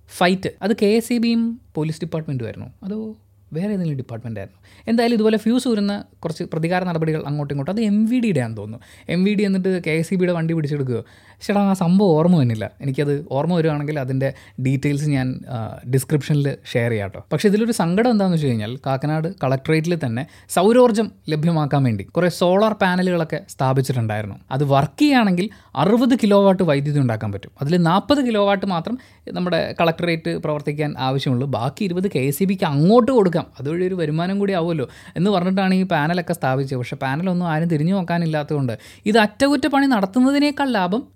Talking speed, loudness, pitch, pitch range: 160 wpm, -20 LUFS, 165 Hz, 135-200 Hz